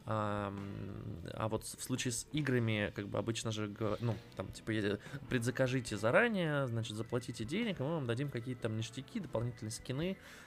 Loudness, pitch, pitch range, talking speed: -37 LUFS, 115 Hz, 110-130 Hz, 155 wpm